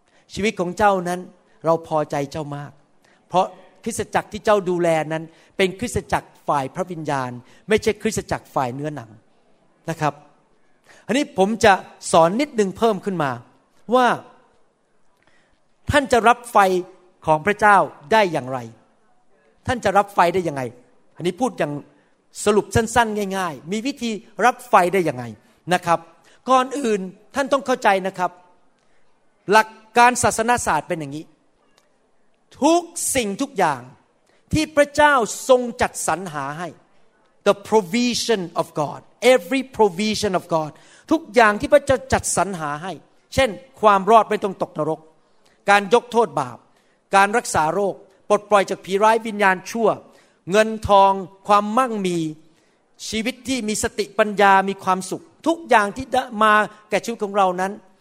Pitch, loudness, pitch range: 200 Hz, -20 LUFS, 165-225 Hz